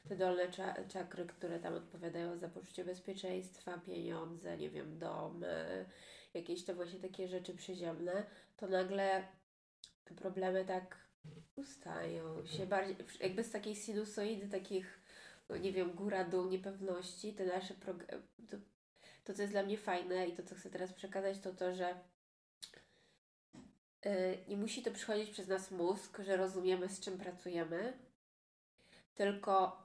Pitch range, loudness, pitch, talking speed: 180-195 Hz, -42 LUFS, 185 Hz, 140 wpm